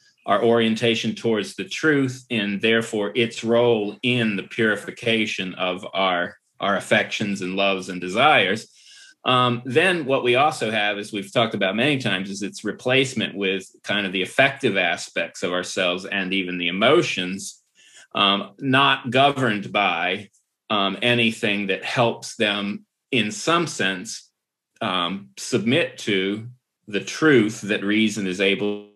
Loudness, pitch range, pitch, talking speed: -21 LUFS, 100-120 Hz, 105 Hz, 140 wpm